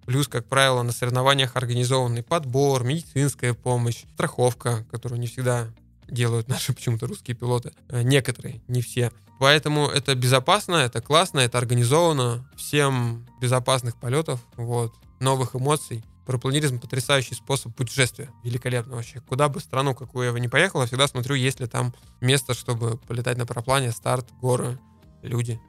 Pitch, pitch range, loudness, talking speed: 125 Hz, 120-135 Hz, -23 LUFS, 145 wpm